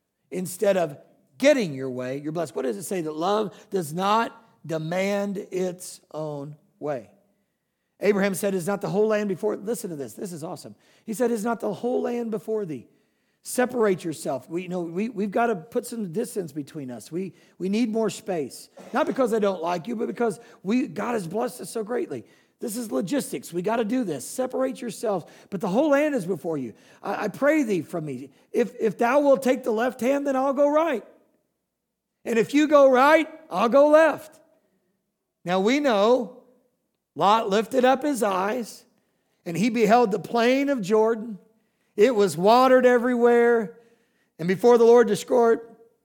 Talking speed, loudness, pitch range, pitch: 185 wpm, -23 LUFS, 190-240 Hz, 220 Hz